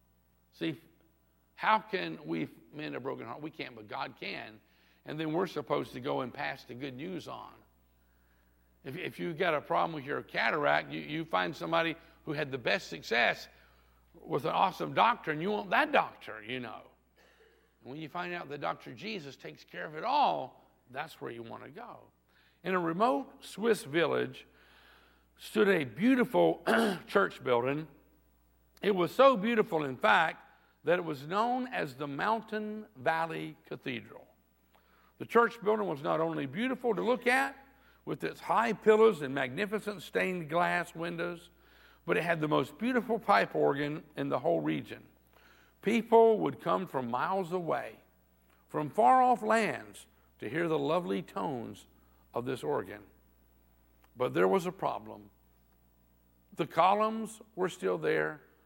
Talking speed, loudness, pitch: 160 wpm, -31 LUFS, 155 Hz